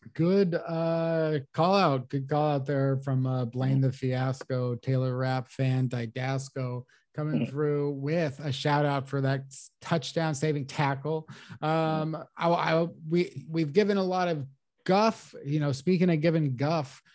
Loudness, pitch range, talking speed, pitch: -28 LUFS, 130-165 Hz, 145 wpm, 145 Hz